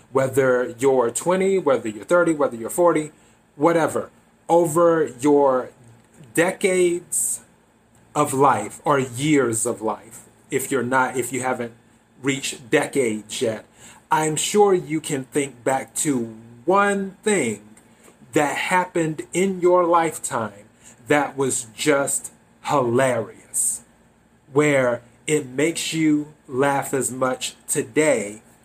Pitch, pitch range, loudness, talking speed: 140 Hz, 120-165 Hz, -21 LUFS, 115 wpm